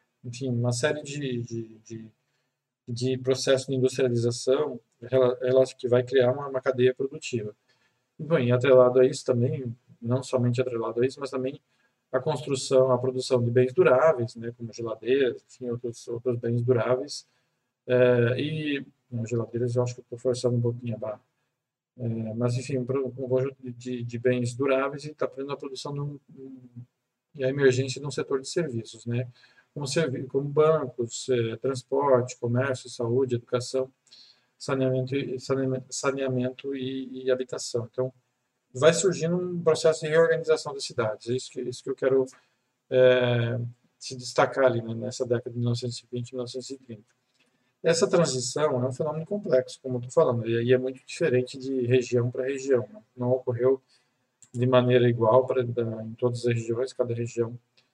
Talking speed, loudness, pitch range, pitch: 160 wpm, -26 LUFS, 125-135 Hz, 125 Hz